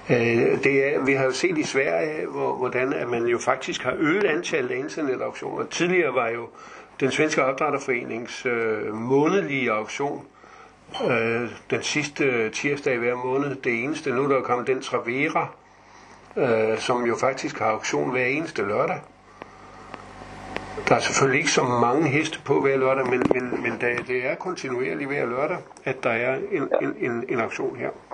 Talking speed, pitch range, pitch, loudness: 170 wpm, 120-140 Hz, 125 Hz, -24 LUFS